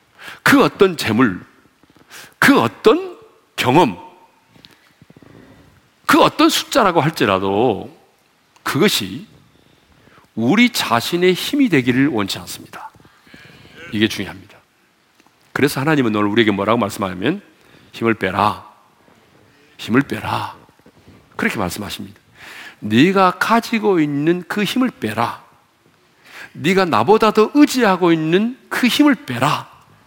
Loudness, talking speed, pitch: -16 LUFS, 225 characters per minute, 165 Hz